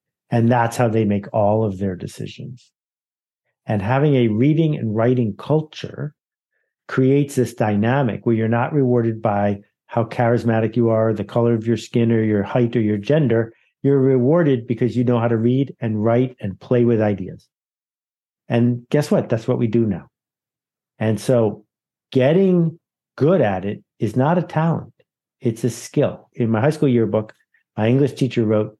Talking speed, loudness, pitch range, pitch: 175 wpm, -19 LUFS, 110-135 Hz, 120 Hz